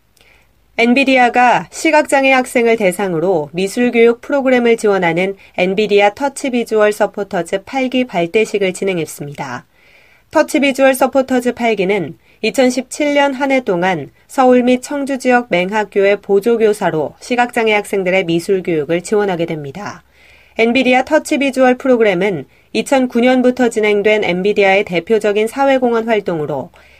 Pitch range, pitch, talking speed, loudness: 195-255 Hz, 220 Hz, 315 characters per minute, -14 LUFS